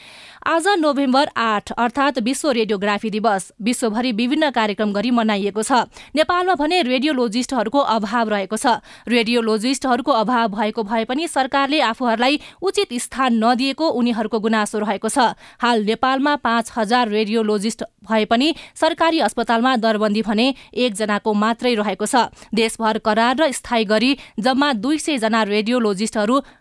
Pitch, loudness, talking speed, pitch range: 235 Hz, -19 LUFS, 130 wpm, 220-270 Hz